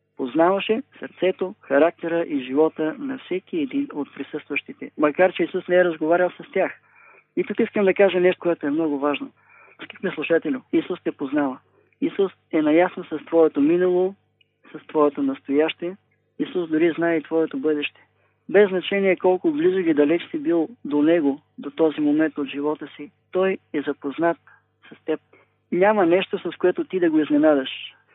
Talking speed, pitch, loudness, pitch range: 165 wpm, 170 Hz, -22 LUFS, 150-200 Hz